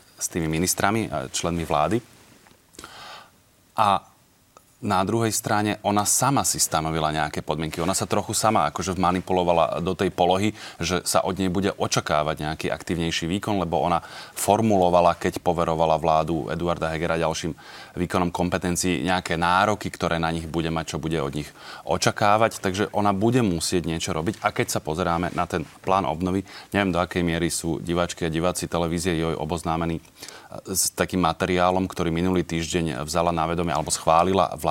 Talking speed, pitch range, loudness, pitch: 165 wpm, 80-95 Hz, -23 LUFS, 90 Hz